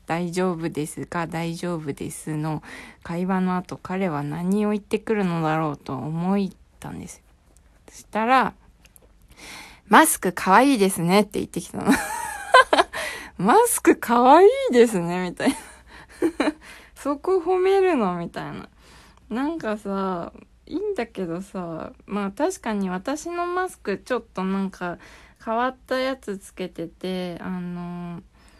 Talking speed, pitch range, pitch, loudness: 260 characters per minute, 175-275 Hz, 195 Hz, -23 LUFS